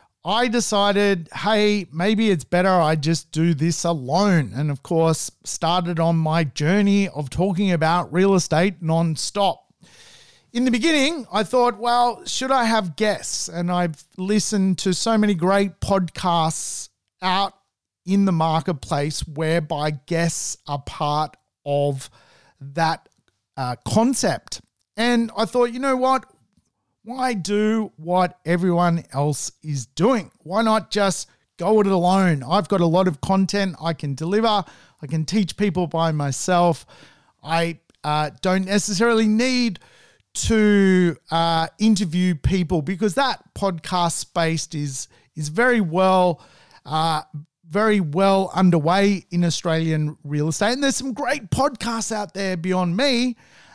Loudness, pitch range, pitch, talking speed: -21 LUFS, 160-210 Hz, 180 Hz, 135 wpm